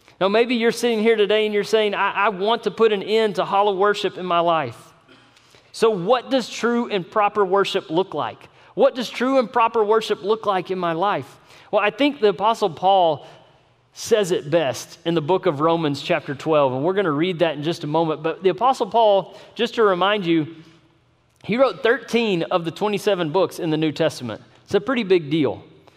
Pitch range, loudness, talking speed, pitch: 165-220 Hz, -20 LUFS, 215 wpm, 195 Hz